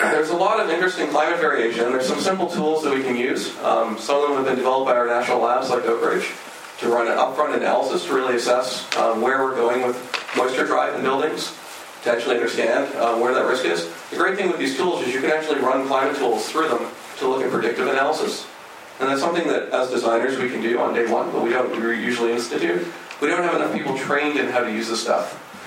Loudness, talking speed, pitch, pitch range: -21 LUFS, 240 wpm, 130 Hz, 120-145 Hz